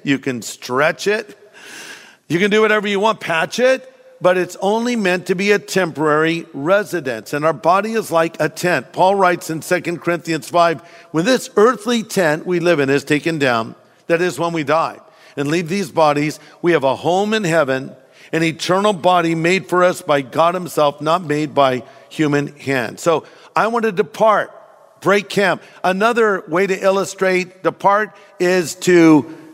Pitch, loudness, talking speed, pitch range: 175 Hz, -17 LUFS, 175 wpm, 155-195 Hz